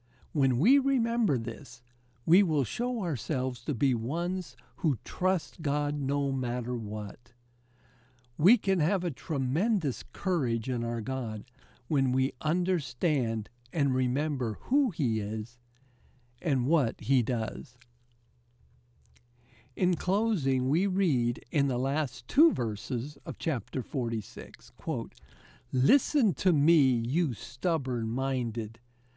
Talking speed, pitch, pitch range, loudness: 115 wpm, 130 Hz, 120-160 Hz, -29 LUFS